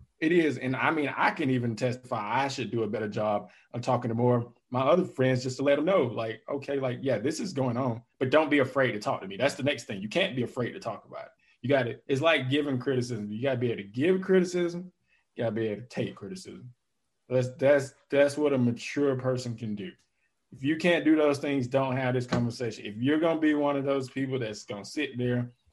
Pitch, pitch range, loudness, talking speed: 130 Hz, 120-140 Hz, -28 LUFS, 250 wpm